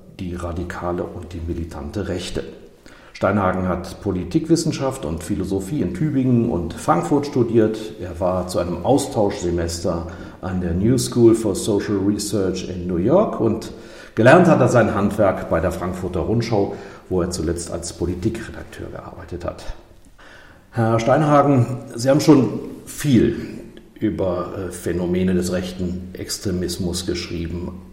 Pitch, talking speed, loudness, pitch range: 95 Hz, 130 wpm, -20 LUFS, 90-115 Hz